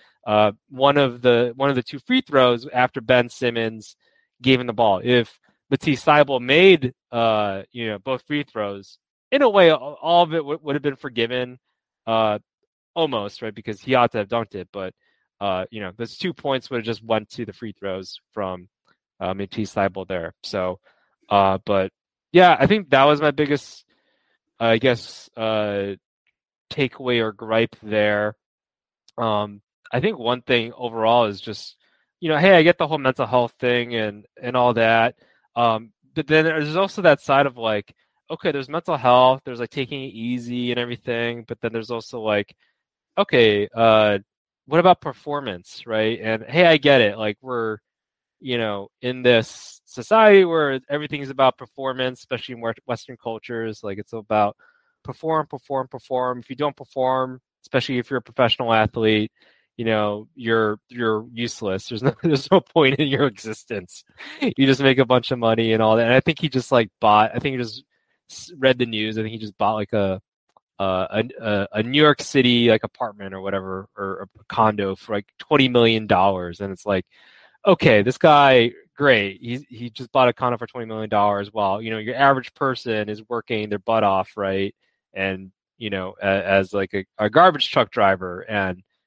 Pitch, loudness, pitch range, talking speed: 120 Hz, -20 LUFS, 105-135 Hz, 190 wpm